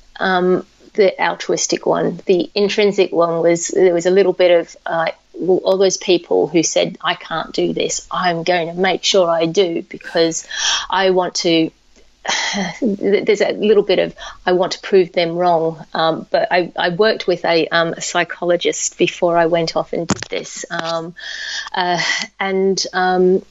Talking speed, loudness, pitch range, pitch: 170 wpm, -17 LUFS, 170-195 Hz, 180 Hz